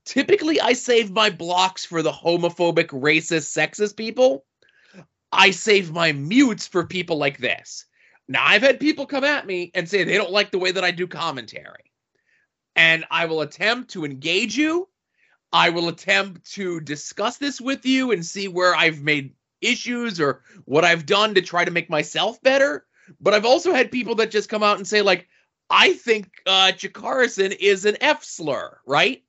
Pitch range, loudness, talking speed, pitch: 165-230 Hz, -20 LUFS, 180 wpm, 195 Hz